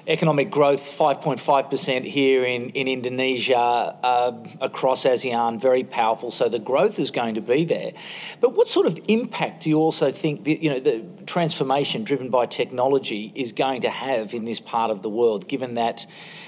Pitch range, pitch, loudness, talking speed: 125-160 Hz, 135 Hz, -22 LUFS, 180 wpm